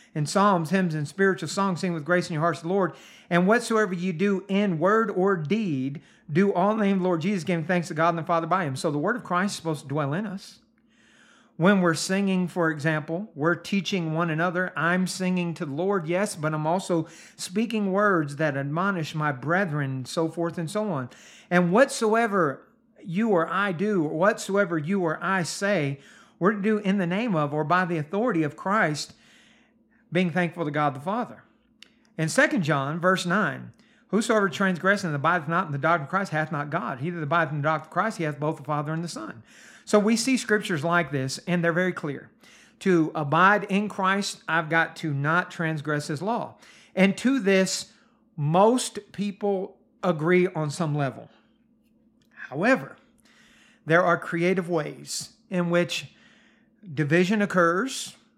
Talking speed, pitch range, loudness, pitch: 190 wpm, 165-205 Hz, -25 LUFS, 180 Hz